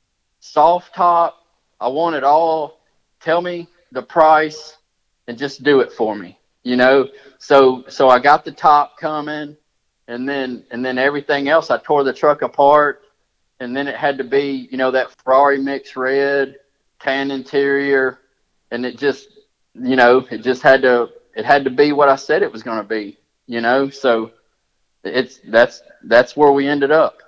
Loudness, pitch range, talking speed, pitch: -16 LUFS, 130-150 Hz, 180 wpm, 140 Hz